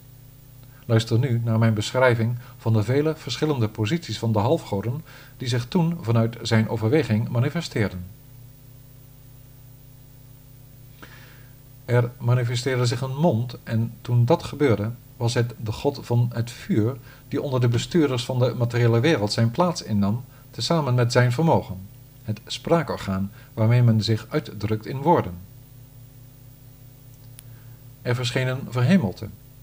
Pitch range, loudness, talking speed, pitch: 115-130 Hz, -23 LUFS, 130 wpm, 125 Hz